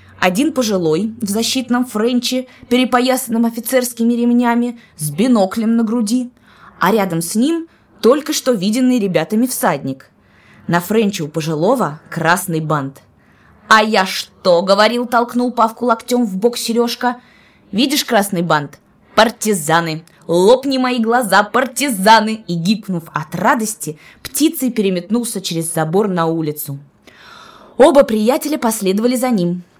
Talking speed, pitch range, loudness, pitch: 120 wpm, 180-245 Hz, -15 LUFS, 220 Hz